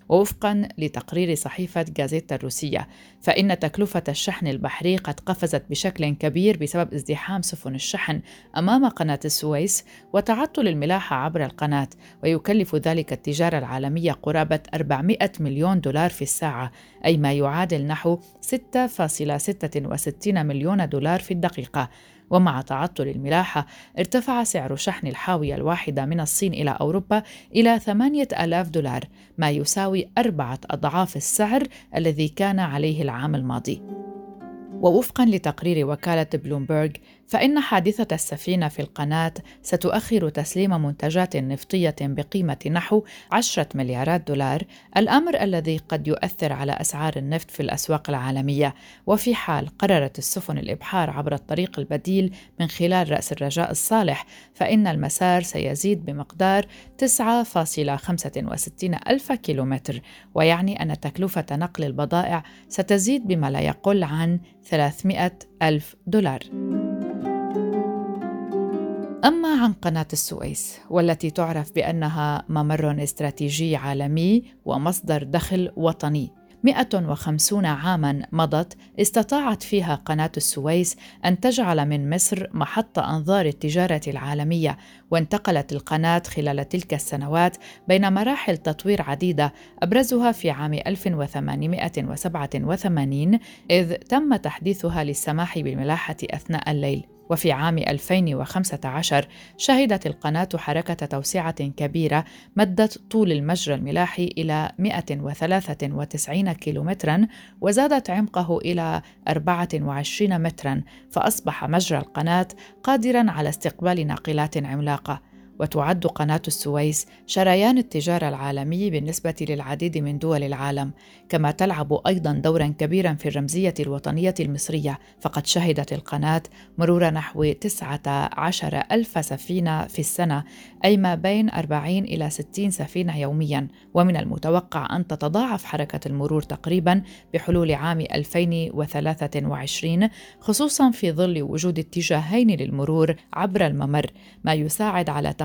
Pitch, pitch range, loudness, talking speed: 165 Hz, 145-190 Hz, -23 LUFS, 110 wpm